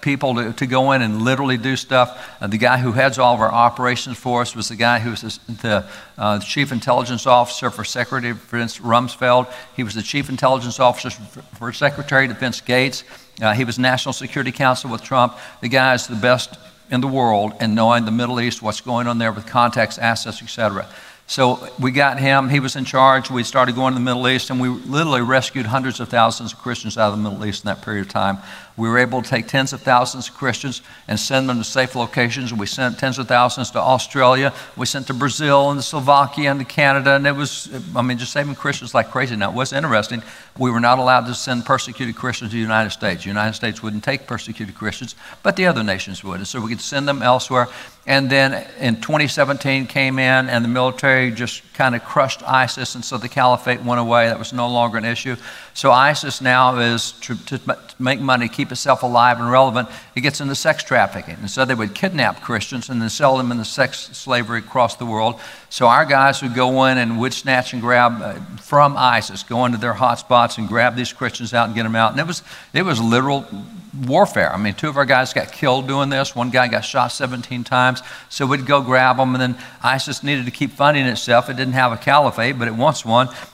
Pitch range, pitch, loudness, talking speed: 115-130 Hz, 125 Hz, -18 LUFS, 230 wpm